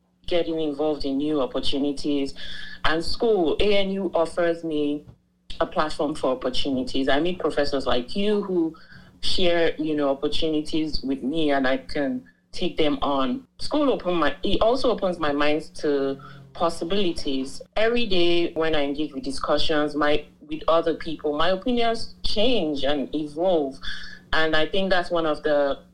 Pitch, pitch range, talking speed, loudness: 155 Hz, 145-175 Hz, 150 wpm, -24 LUFS